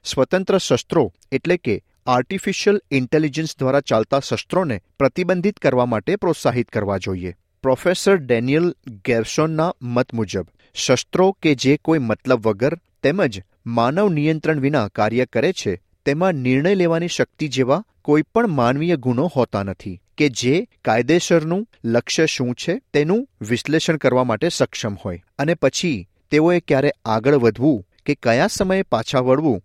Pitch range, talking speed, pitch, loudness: 120-170 Hz, 135 wpm, 140 Hz, -19 LUFS